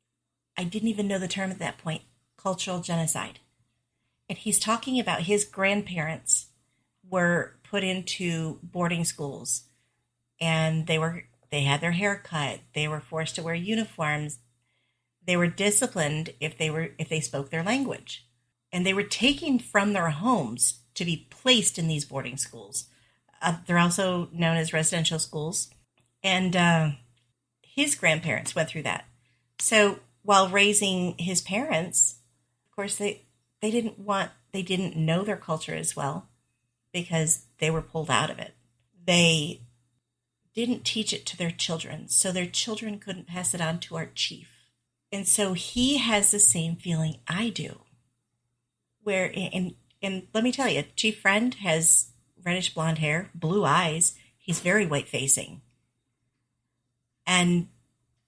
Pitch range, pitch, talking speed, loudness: 140-195 Hz, 165 Hz, 150 wpm, -26 LUFS